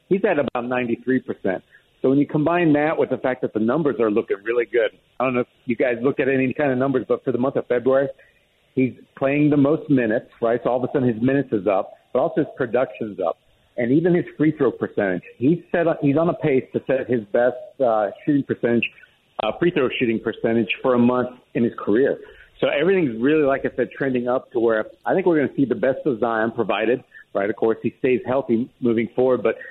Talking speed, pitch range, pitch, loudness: 240 wpm, 120-145 Hz, 130 Hz, -21 LUFS